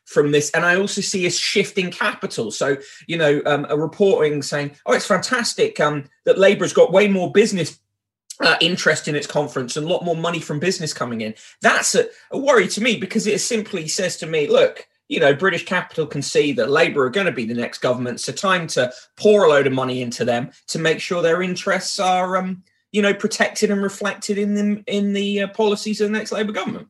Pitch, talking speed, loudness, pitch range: 185 Hz, 230 wpm, -19 LUFS, 150-205 Hz